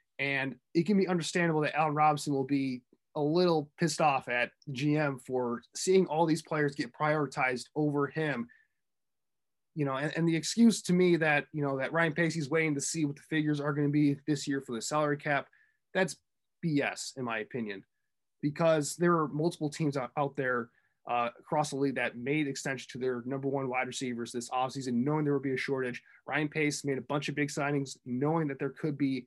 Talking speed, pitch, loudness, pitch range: 210 wpm, 145 Hz, -31 LUFS, 135-155 Hz